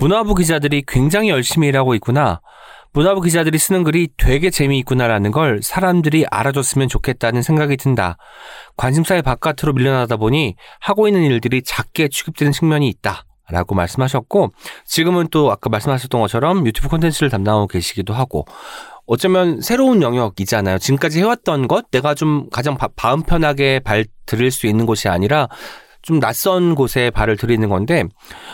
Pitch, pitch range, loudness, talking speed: 135 Hz, 120-160 Hz, -16 LUFS, 380 characters per minute